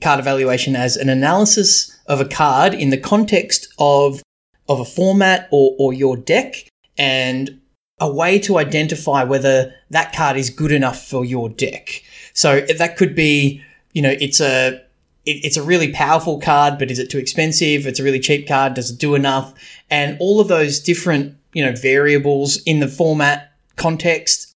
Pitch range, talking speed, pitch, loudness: 135-160 Hz, 180 wpm, 145 Hz, -16 LUFS